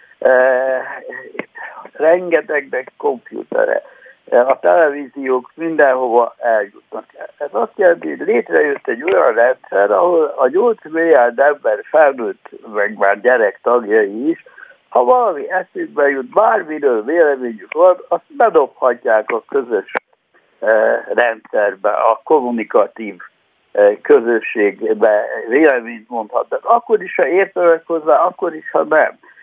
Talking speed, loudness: 105 wpm, -15 LUFS